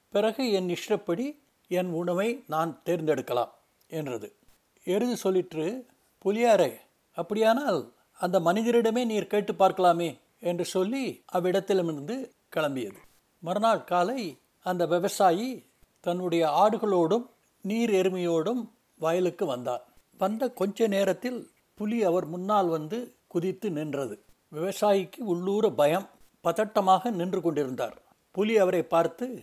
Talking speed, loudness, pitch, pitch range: 100 wpm, -28 LUFS, 190 Hz, 175-220 Hz